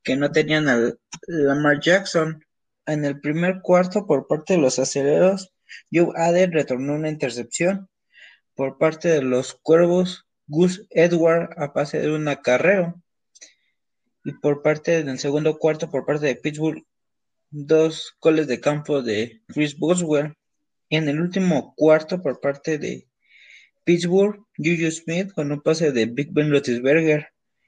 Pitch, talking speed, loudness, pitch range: 155 Hz, 145 wpm, -21 LUFS, 145-170 Hz